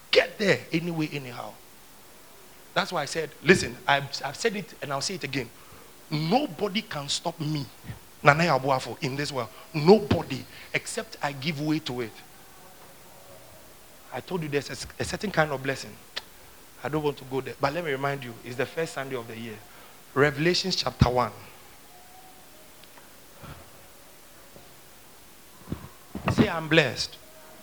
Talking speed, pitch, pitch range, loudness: 140 wpm, 145 Hz, 130-165 Hz, -27 LUFS